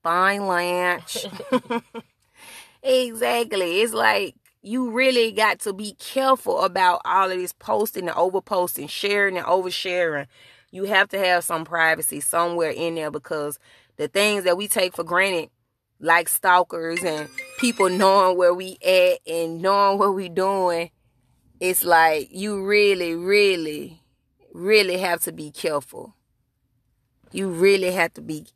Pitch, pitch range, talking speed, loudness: 185 Hz, 165-200 Hz, 140 wpm, -21 LUFS